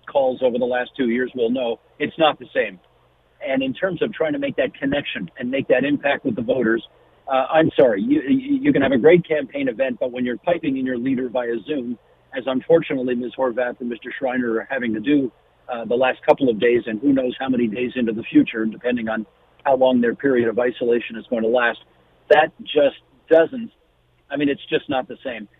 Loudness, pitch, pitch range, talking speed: -20 LUFS, 130 Hz, 120-180 Hz, 225 wpm